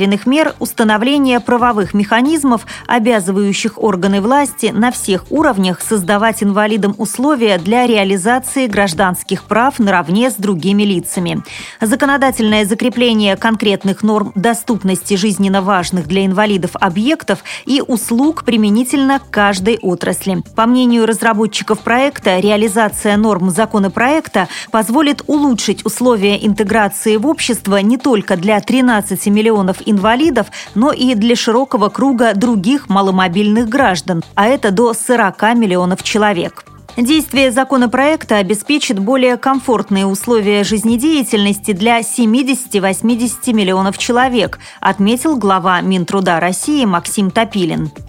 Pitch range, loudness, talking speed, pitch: 200-245 Hz, -13 LUFS, 110 wpm, 220 Hz